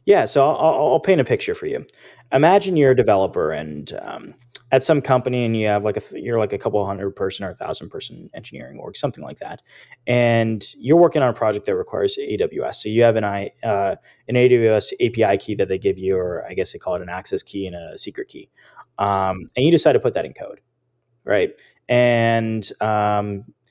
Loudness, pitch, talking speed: -19 LUFS, 120 Hz, 220 wpm